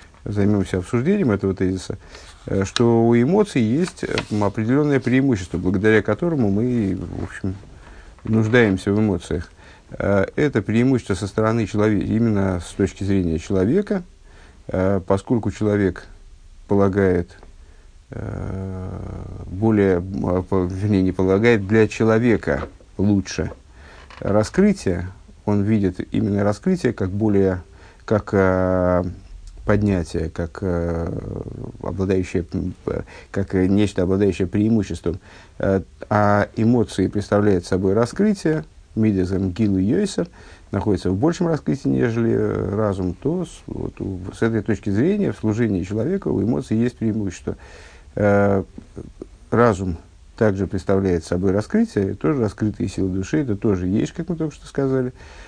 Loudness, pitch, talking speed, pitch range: -21 LUFS, 100 Hz, 110 wpm, 95-110 Hz